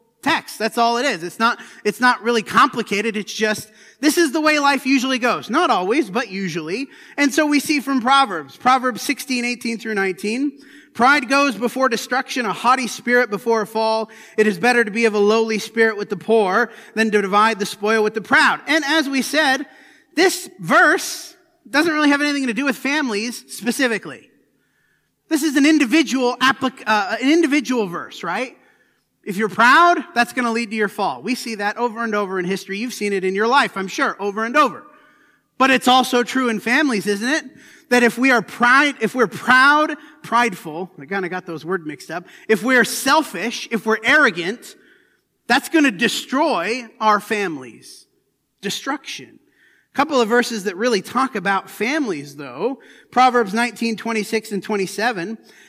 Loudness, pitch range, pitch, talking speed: -18 LUFS, 215-280 Hz, 240 Hz, 185 wpm